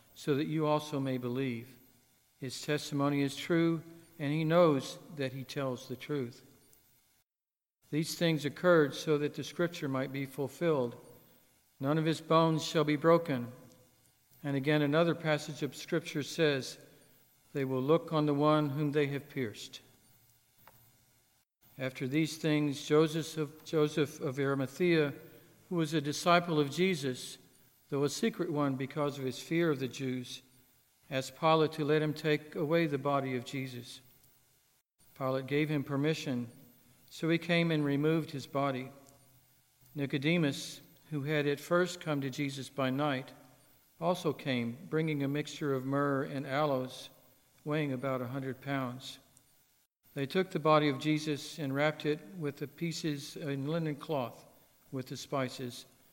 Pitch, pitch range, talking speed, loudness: 145 Hz, 130-155 Hz, 150 wpm, -33 LUFS